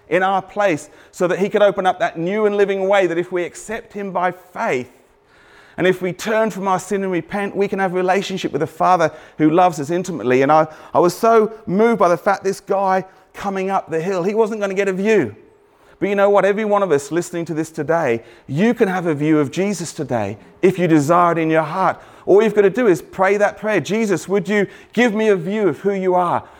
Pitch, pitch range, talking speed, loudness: 190 Hz, 170-205 Hz, 250 wpm, -18 LUFS